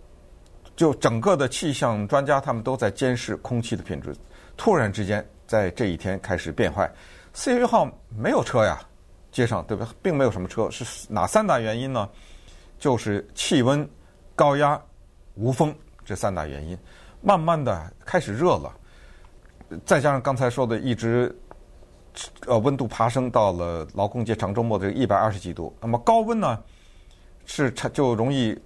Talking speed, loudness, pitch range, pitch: 240 characters per minute, -24 LUFS, 90-135 Hz, 115 Hz